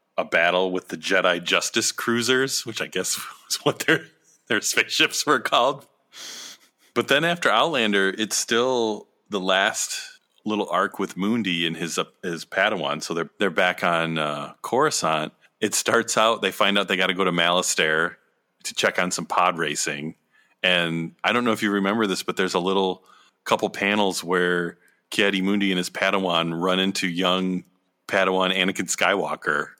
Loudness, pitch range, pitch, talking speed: -22 LUFS, 90-100 Hz, 95 Hz, 175 wpm